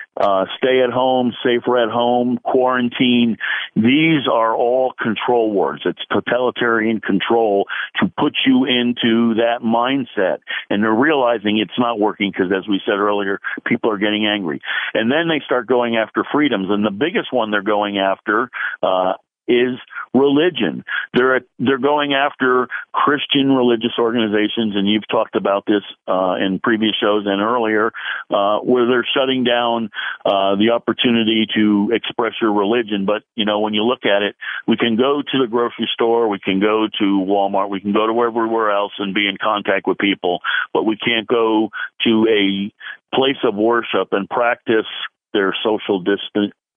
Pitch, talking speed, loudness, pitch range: 115 Hz, 170 wpm, -17 LUFS, 105-125 Hz